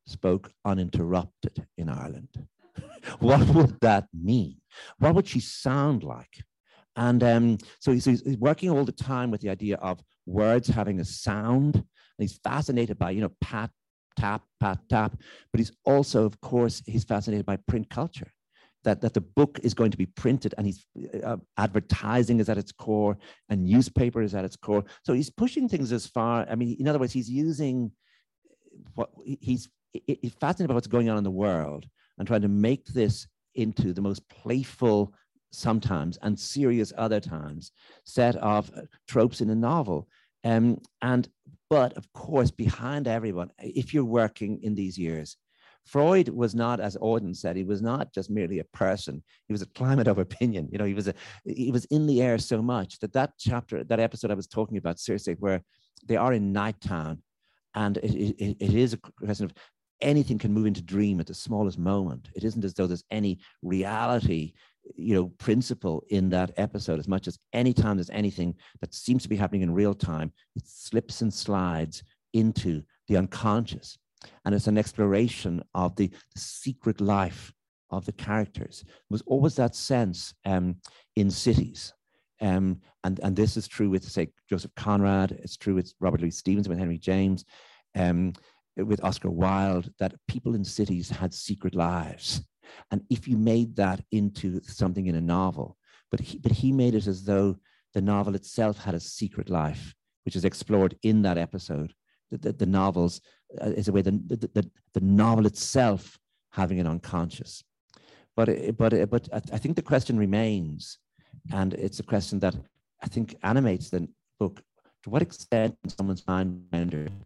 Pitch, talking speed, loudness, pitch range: 105 Hz, 180 wpm, -27 LUFS, 95-120 Hz